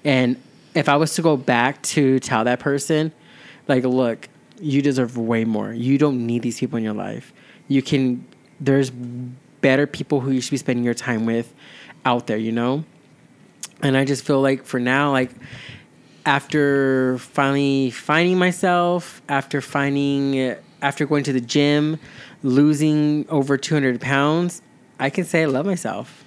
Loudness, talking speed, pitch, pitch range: -20 LUFS, 160 wpm, 140 Hz, 125-150 Hz